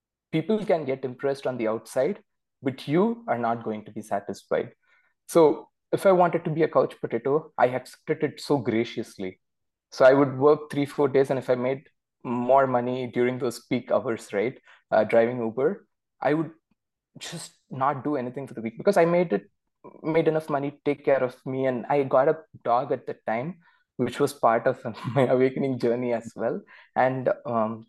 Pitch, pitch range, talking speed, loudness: 130 Hz, 120-150 Hz, 195 wpm, -25 LUFS